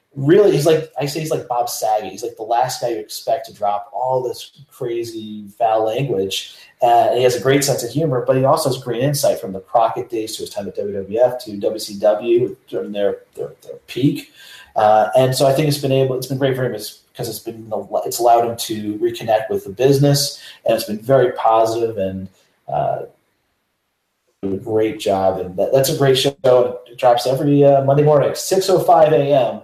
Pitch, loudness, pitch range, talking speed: 125 Hz, -17 LUFS, 110-145 Hz, 210 wpm